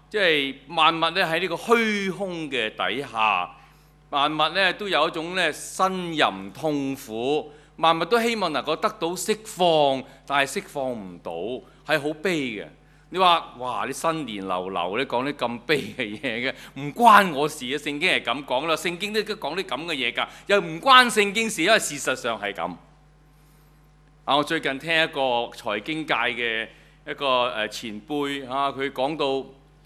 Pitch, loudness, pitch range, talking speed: 150 Hz, -23 LUFS, 135-170 Hz, 230 characters per minute